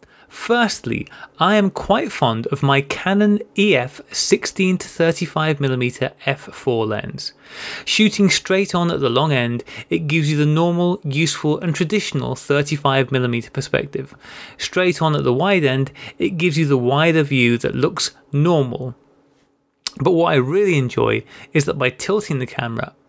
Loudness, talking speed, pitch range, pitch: -18 LUFS, 145 wpm, 135-180 Hz, 150 Hz